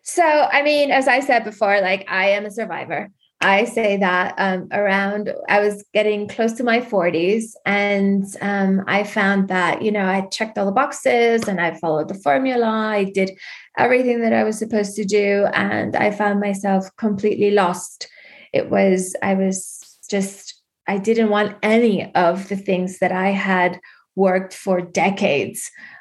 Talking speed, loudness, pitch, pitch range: 170 wpm, -19 LUFS, 200 Hz, 190-215 Hz